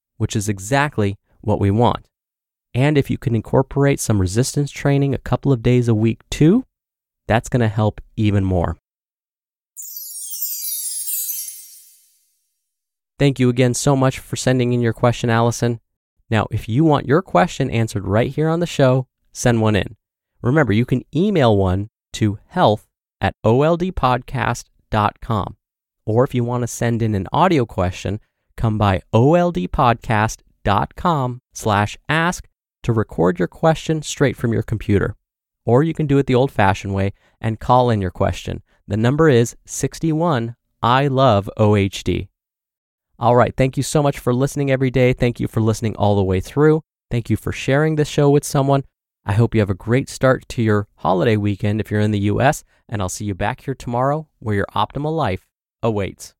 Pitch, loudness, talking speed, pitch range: 115 Hz, -19 LUFS, 170 wpm, 105-135 Hz